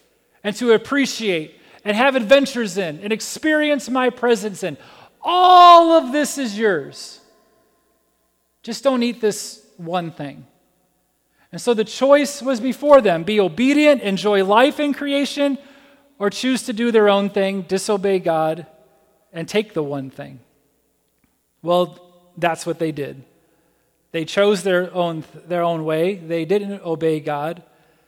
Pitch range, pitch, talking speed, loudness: 165-250 Hz, 200 Hz, 140 wpm, -18 LUFS